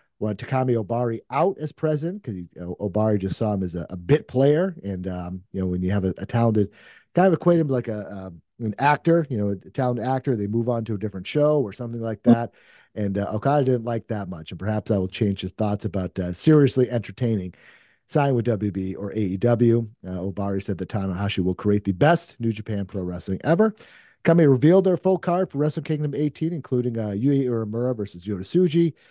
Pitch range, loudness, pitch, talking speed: 100-140 Hz, -23 LUFS, 115 Hz, 215 wpm